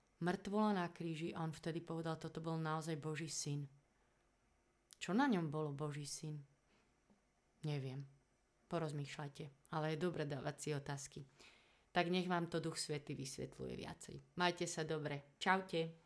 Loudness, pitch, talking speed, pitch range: -43 LUFS, 160 Hz, 140 wpm, 145-170 Hz